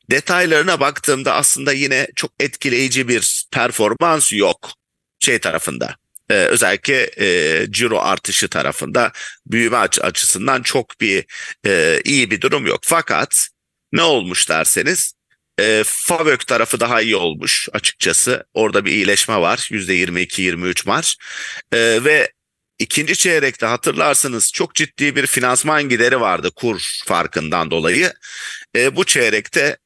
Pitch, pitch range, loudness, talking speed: 130 Hz, 105-170 Hz, -15 LUFS, 120 wpm